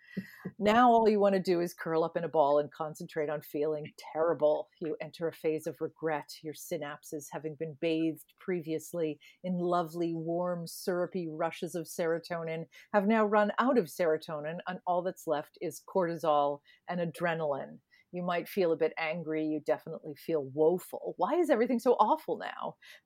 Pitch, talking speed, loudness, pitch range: 165 Hz, 170 wpm, -32 LUFS, 155-180 Hz